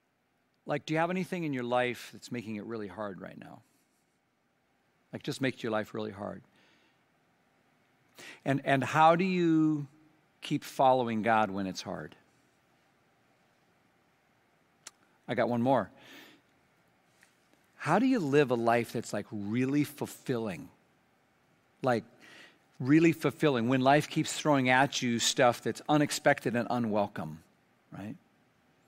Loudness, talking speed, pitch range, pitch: -29 LUFS, 130 wpm, 110-150 Hz, 130 Hz